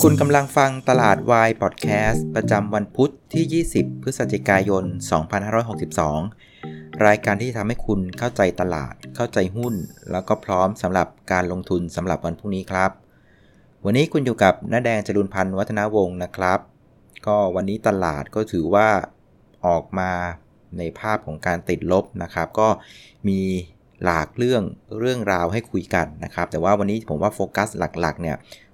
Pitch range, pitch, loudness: 90-110 Hz, 100 Hz, -21 LUFS